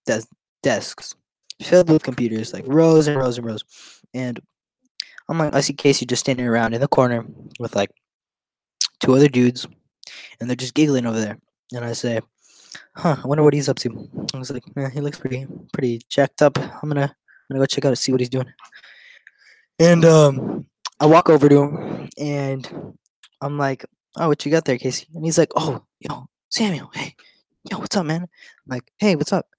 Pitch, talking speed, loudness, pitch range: 140 Hz, 200 wpm, -19 LUFS, 125-155 Hz